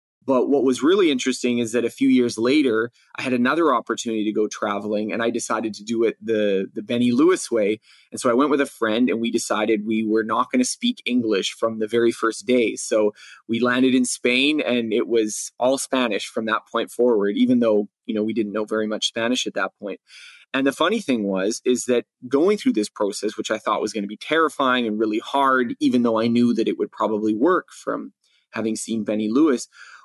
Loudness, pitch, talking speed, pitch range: -21 LUFS, 115 Hz, 230 wpm, 110-130 Hz